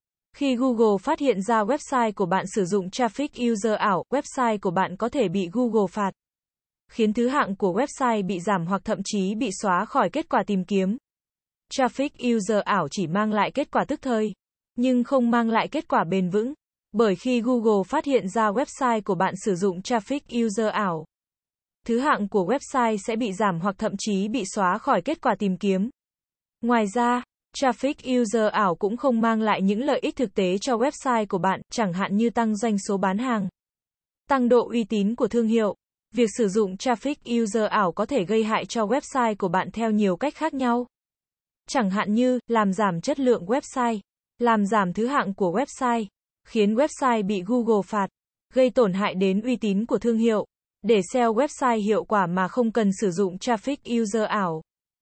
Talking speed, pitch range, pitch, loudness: 195 wpm, 200-250 Hz, 225 Hz, -24 LUFS